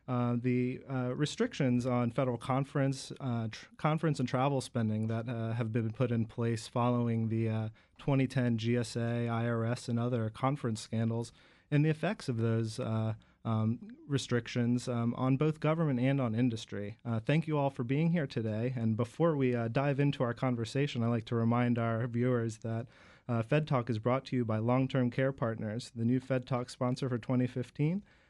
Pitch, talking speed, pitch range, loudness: 125 Hz, 180 wpm, 115-135 Hz, -33 LUFS